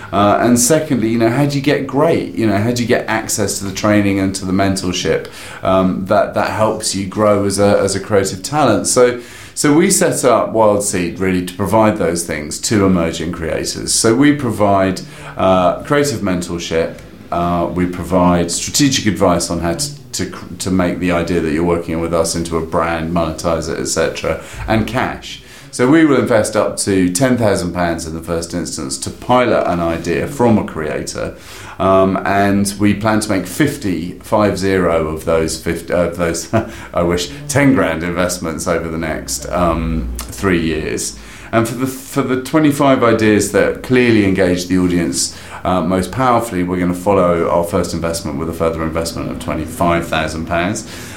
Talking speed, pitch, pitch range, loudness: 185 wpm, 95 Hz, 85-110 Hz, -15 LUFS